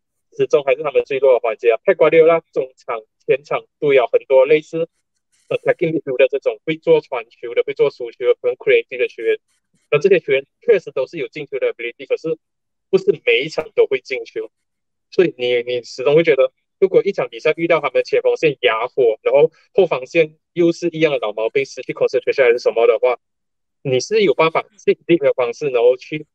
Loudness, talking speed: -17 LUFS, 360 characters per minute